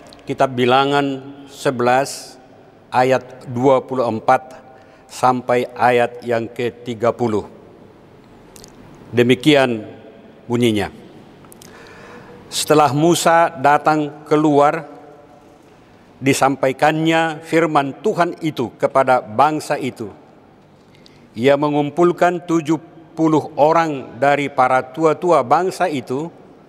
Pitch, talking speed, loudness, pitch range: 140 Hz, 70 wpm, -17 LUFS, 125-150 Hz